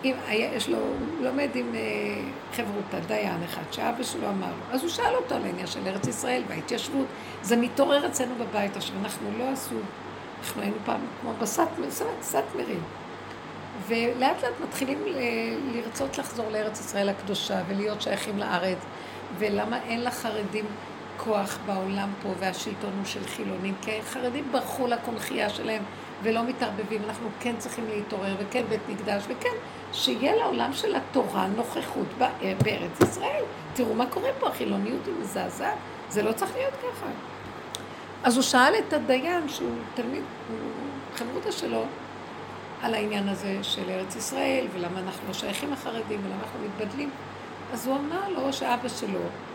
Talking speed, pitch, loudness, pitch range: 150 wpm, 230 Hz, -29 LUFS, 210-260 Hz